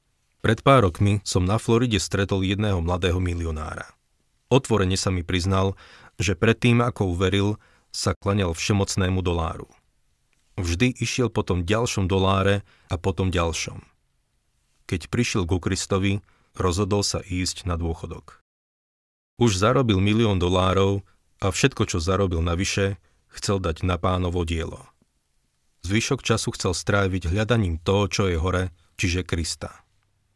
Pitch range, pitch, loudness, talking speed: 90-105 Hz, 95 Hz, -23 LUFS, 130 wpm